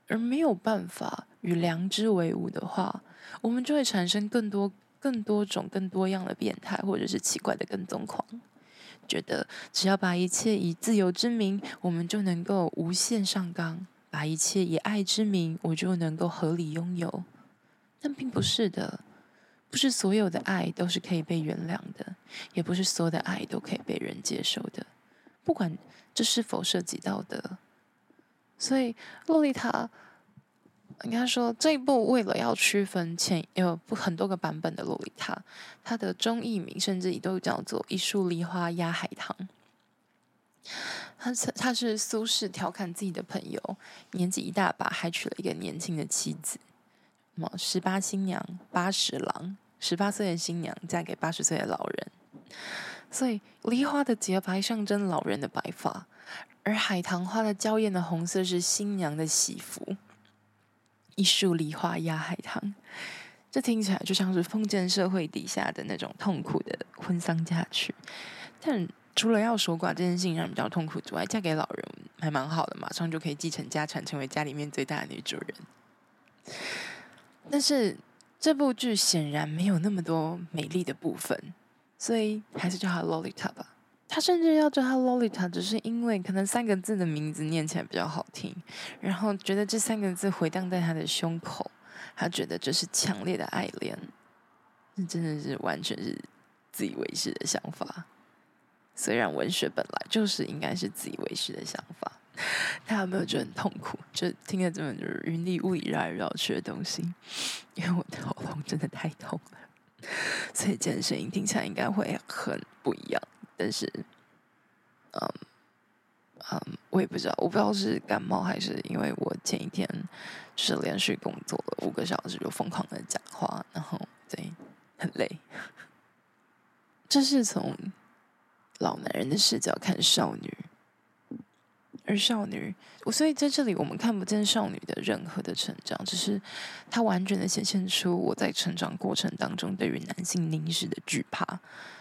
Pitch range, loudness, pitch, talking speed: 175-220 Hz, -30 LUFS, 190 Hz, 250 characters per minute